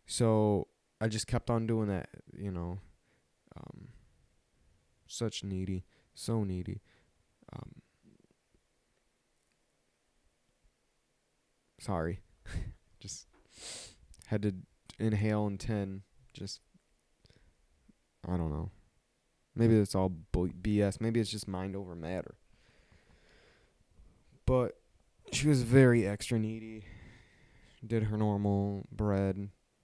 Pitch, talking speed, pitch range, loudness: 100 Hz, 95 wpm, 95-110 Hz, -33 LUFS